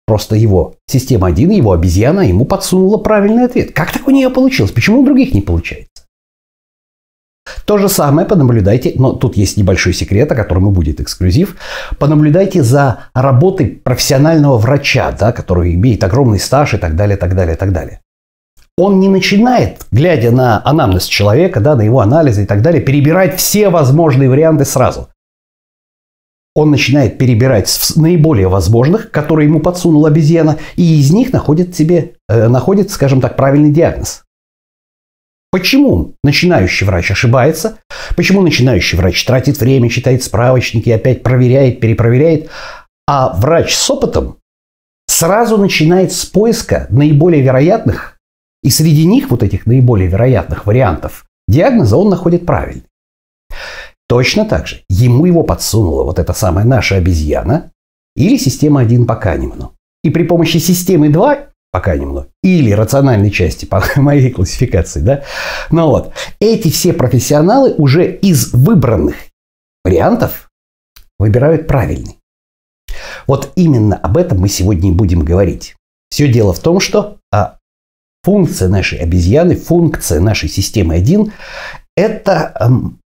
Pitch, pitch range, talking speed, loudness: 130 Hz, 95-160 Hz, 140 wpm, -10 LUFS